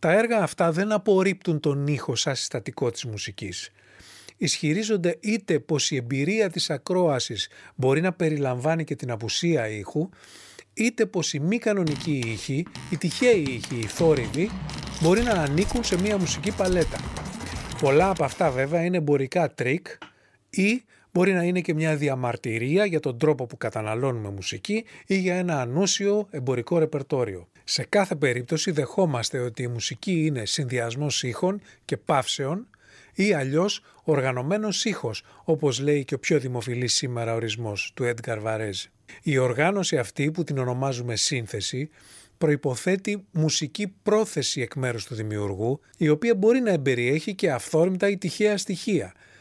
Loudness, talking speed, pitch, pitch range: -25 LUFS, 150 wpm, 155 Hz, 125-185 Hz